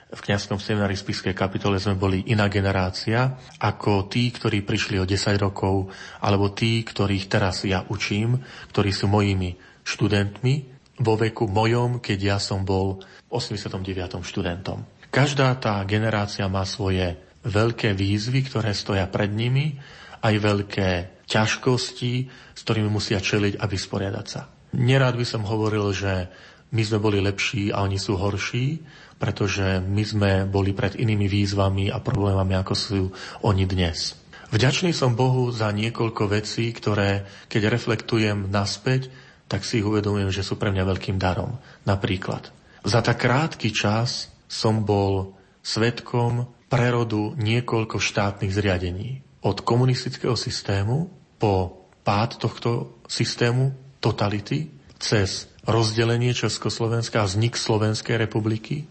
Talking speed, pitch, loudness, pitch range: 130 wpm, 105 Hz, -24 LUFS, 100-120 Hz